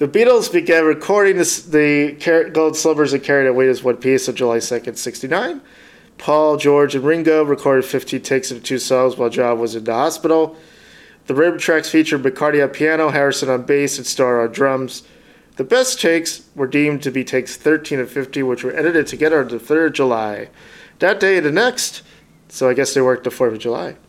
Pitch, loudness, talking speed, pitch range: 145 Hz, -16 LUFS, 205 wpm, 130-160 Hz